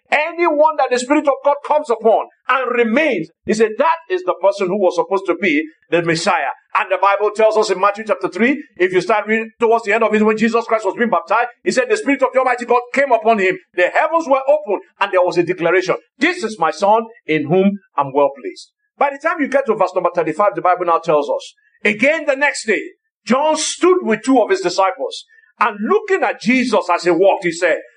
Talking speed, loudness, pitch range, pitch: 235 wpm, -16 LUFS, 195-300 Hz, 230 Hz